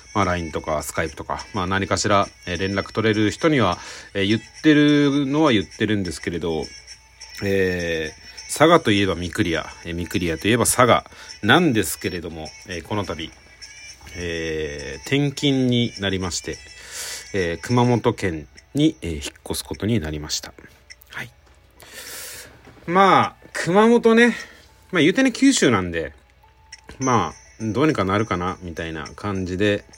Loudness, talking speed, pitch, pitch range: -21 LUFS, 290 characters per minute, 100 Hz, 85-120 Hz